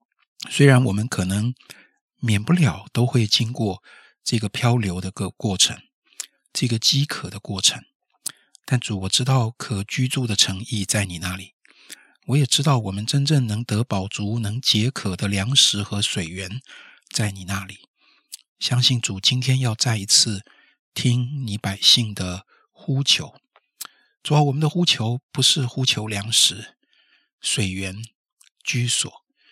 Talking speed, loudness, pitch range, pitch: 205 characters per minute, -20 LUFS, 100-130 Hz, 115 Hz